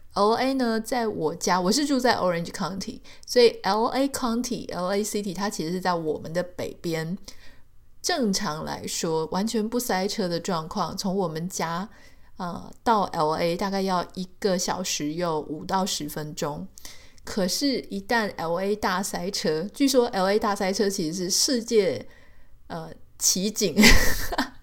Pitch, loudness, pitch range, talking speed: 195 Hz, -25 LUFS, 180-225 Hz, 255 characters per minute